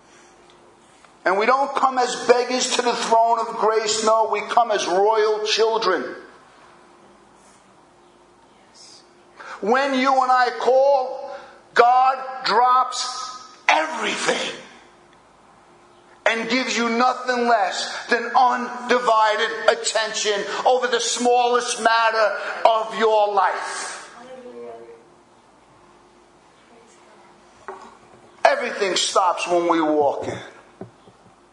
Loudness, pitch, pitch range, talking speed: -19 LUFS, 235 Hz, 220-250 Hz, 90 wpm